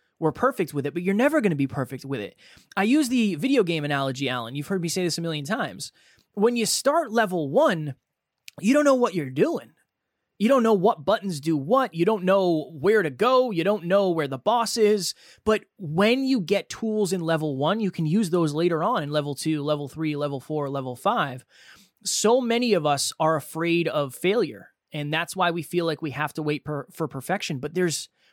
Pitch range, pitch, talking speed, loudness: 150-215 Hz, 170 Hz, 220 wpm, -24 LUFS